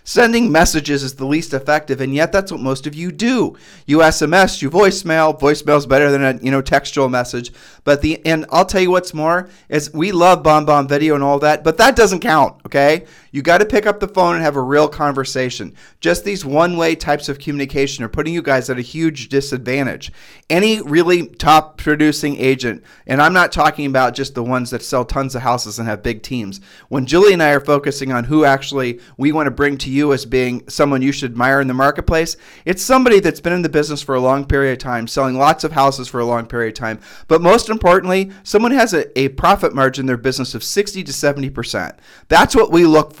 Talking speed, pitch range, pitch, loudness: 230 wpm, 135-165 Hz, 145 Hz, -15 LUFS